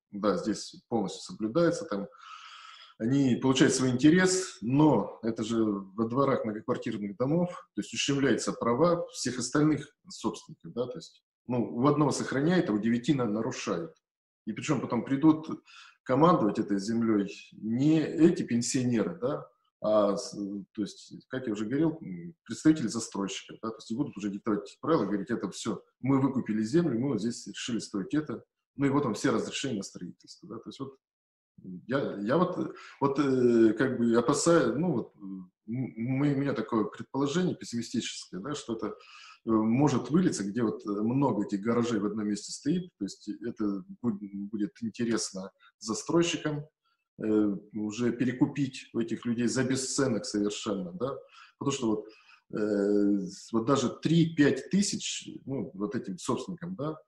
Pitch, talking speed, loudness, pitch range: 120 Hz, 150 wpm, -29 LUFS, 105-150 Hz